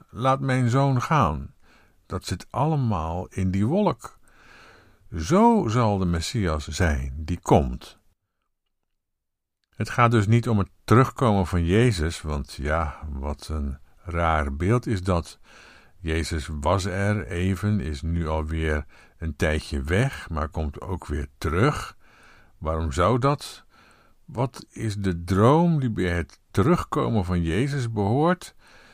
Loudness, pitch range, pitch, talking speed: -24 LUFS, 80-115 Hz, 90 Hz, 130 wpm